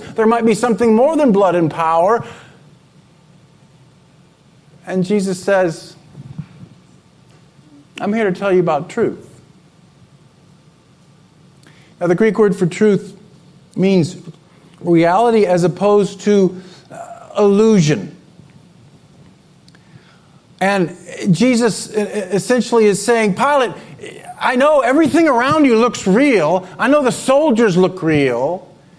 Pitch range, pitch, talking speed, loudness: 165-215 Hz, 180 Hz, 105 wpm, -14 LUFS